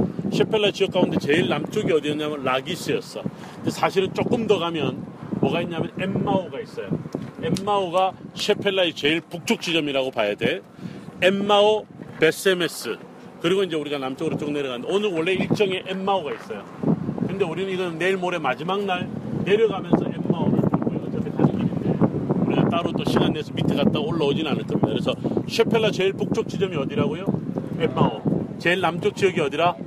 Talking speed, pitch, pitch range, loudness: 380 characters per minute, 185 Hz, 165-200 Hz, -23 LUFS